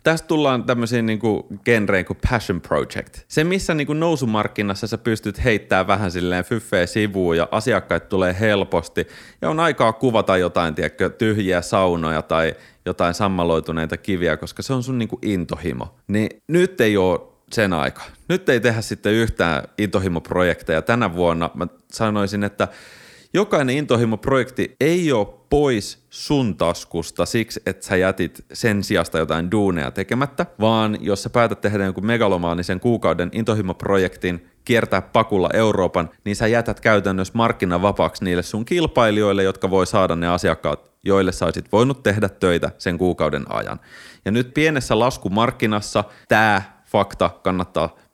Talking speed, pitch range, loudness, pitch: 145 wpm, 90-115 Hz, -20 LUFS, 105 Hz